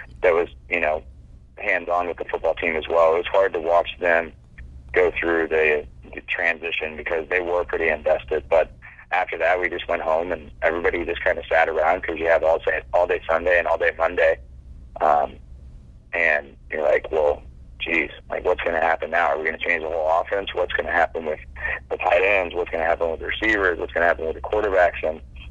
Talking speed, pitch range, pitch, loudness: 220 wpm, 60-75 Hz, 65 Hz, -22 LUFS